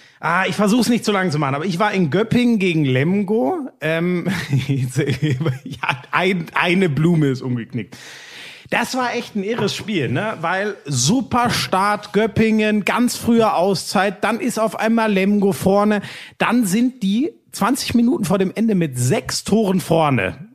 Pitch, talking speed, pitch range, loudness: 195 Hz, 155 wpm, 160-220 Hz, -18 LUFS